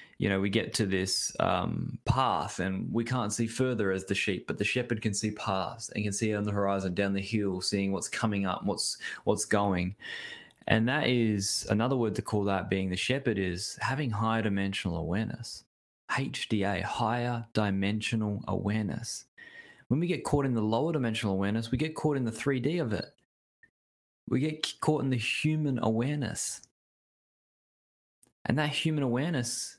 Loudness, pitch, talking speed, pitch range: -30 LUFS, 110 Hz, 175 wpm, 100-125 Hz